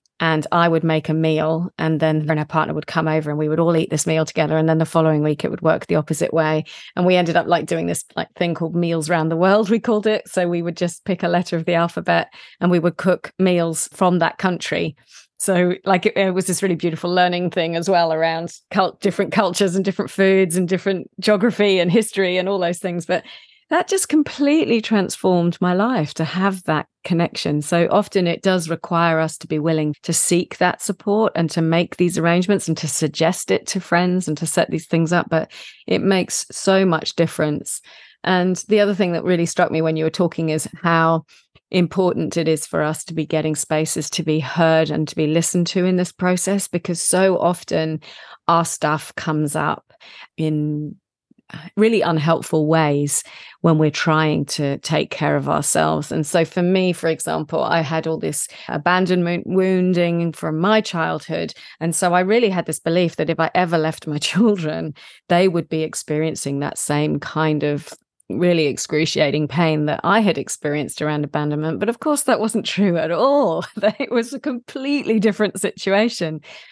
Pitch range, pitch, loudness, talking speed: 160-190 Hz, 170 Hz, -19 LUFS, 200 wpm